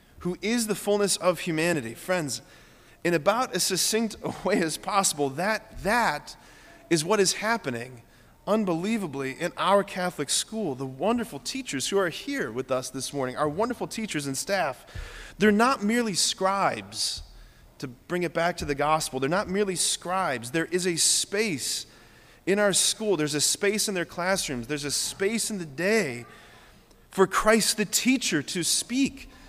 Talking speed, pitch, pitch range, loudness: 165 wpm, 180 Hz, 145-210 Hz, -26 LUFS